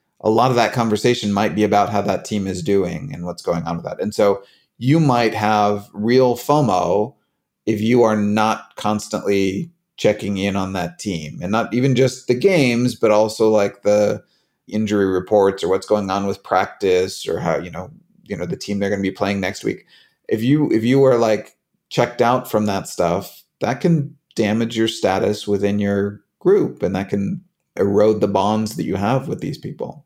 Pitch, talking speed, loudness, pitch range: 105 Hz, 200 wpm, -19 LUFS, 100-120 Hz